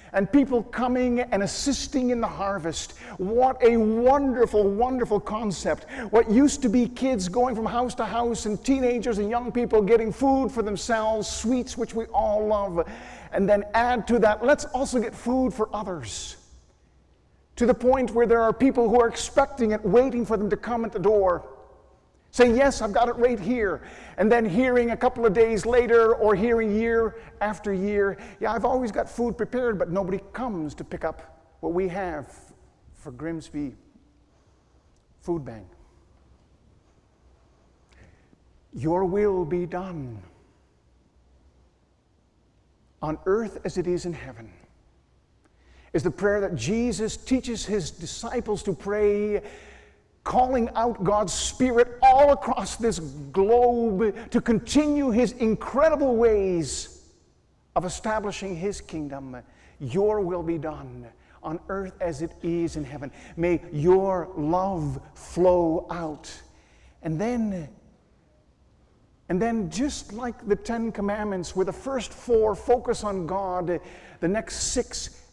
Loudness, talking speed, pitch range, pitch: -24 LUFS, 145 wpm, 170-235 Hz, 210 Hz